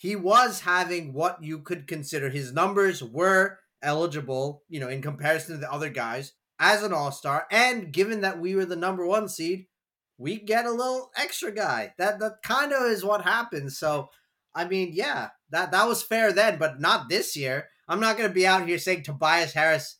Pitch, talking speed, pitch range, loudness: 180 Hz, 200 wpm, 155-205 Hz, -25 LUFS